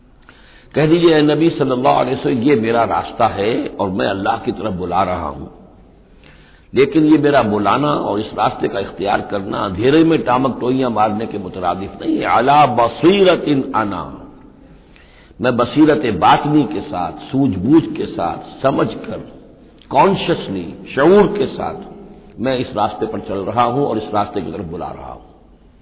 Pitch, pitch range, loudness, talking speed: 130 Hz, 105-150 Hz, -16 LUFS, 160 wpm